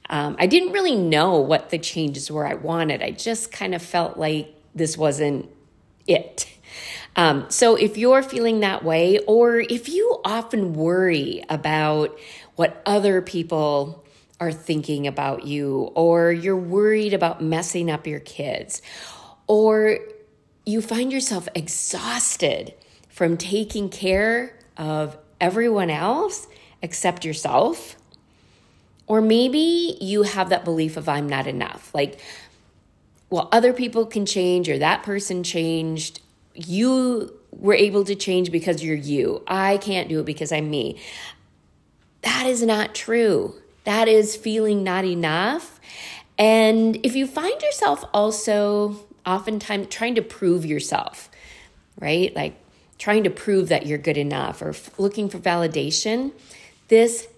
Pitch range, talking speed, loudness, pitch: 160-220 Hz, 135 wpm, -21 LUFS, 185 Hz